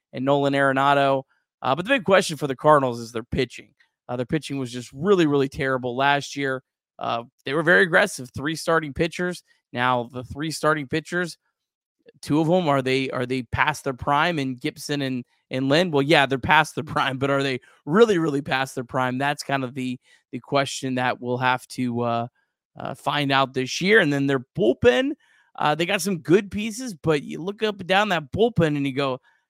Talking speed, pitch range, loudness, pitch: 210 wpm, 130-165 Hz, -22 LUFS, 140 Hz